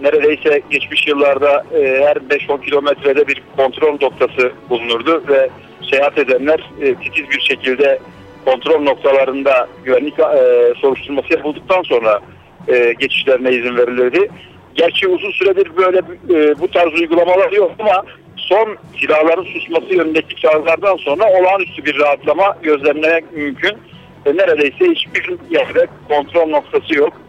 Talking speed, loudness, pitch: 125 wpm, -14 LUFS, 155 Hz